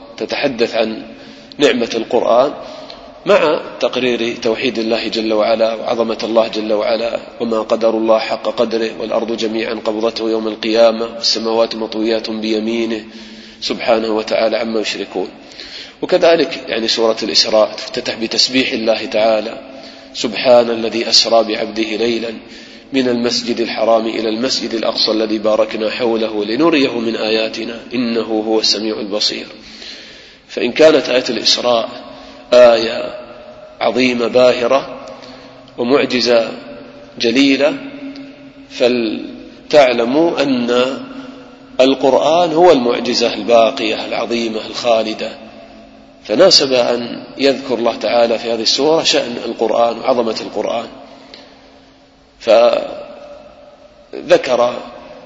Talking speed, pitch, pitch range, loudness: 100 wpm, 115 Hz, 110-125 Hz, -14 LUFS